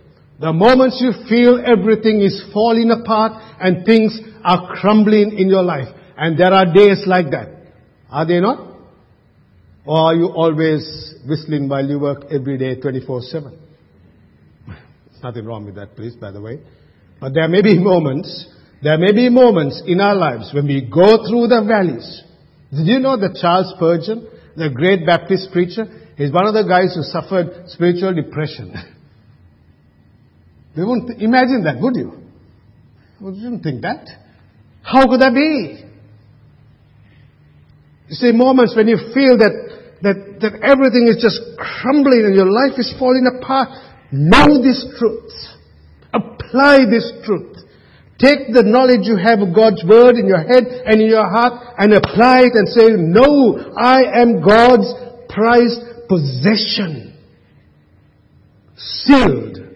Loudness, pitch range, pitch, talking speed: -13 LUFS, 145-230 Hz, 190 Hz, 150 wpm